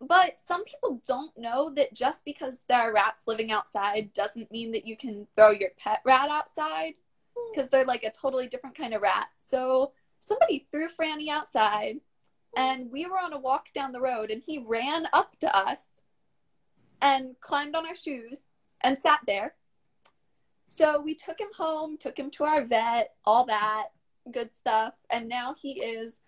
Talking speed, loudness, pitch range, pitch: 180 wpm, -28 LUFS, 225-300 Hz, 265 Hz